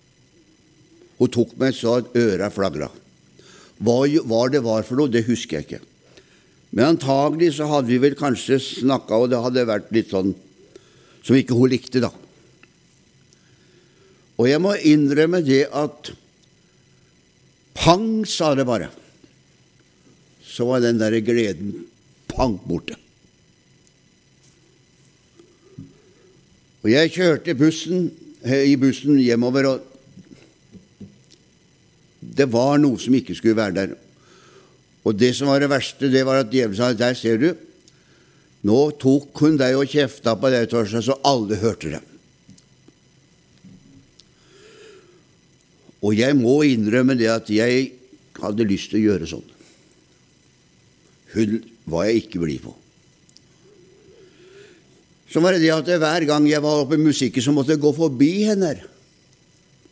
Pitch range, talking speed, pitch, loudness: 115-150 Hz, 135 wpm, 130 Hz, -19 LUFS